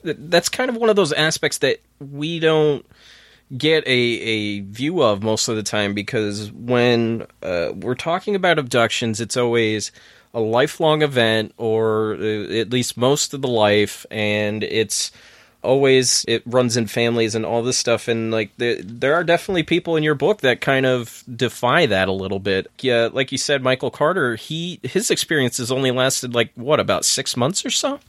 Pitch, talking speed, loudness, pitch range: 125 Hz, 185 wpm, -19 LUFS, 110-150 Hz